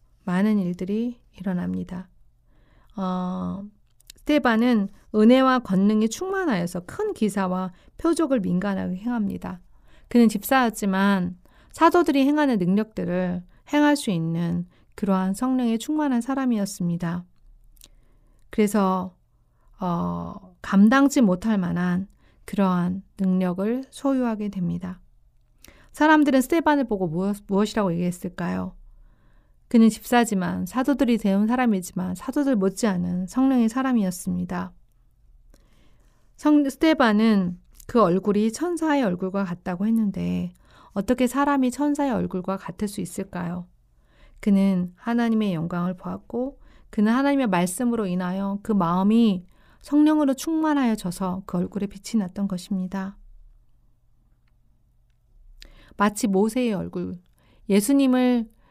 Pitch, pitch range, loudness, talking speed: 195 Hz, 180-240 Hz, -23 LUFS, 270 characters per minute